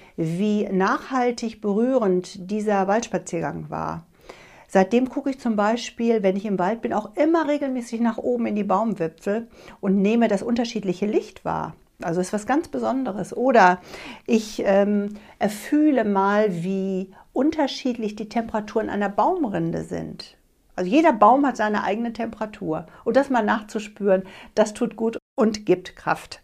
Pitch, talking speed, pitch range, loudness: 215 Hz, 145 wpm, 195-240 Hz, -23 LUFS